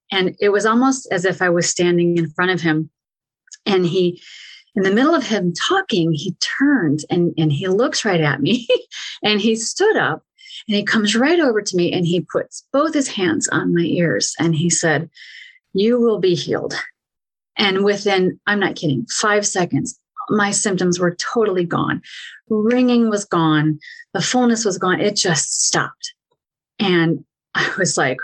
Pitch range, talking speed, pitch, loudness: 175-230 Hz, 175 wpm, 195 Hz, -18 LUFS